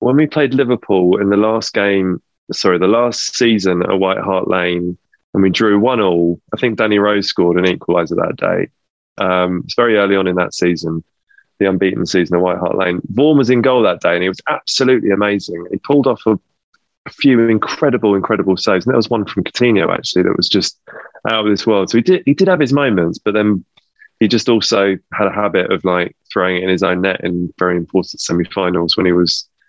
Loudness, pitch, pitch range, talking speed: -15 LUFS, 100 Hz, 90-115 Hz, 225 wpm